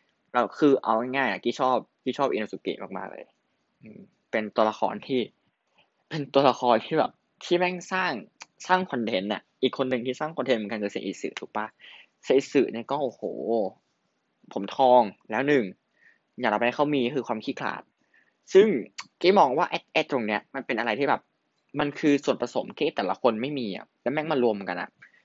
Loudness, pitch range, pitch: -26 LUFS, 115-145 Hz, 130 Hz